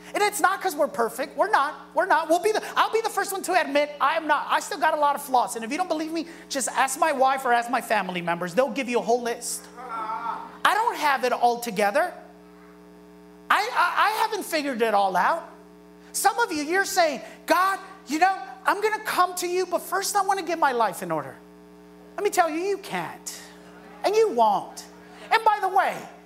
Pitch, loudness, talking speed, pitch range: 295 Hz, -24 LUFS, 235 wpm, 225-370 Hz